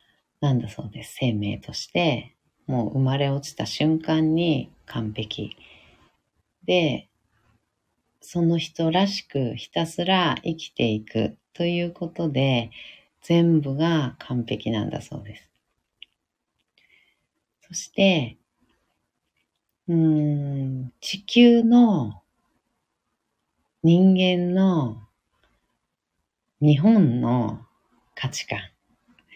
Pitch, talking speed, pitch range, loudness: 140 Hz, 155 characters per minute, 115-170 Hz, -23 LUFS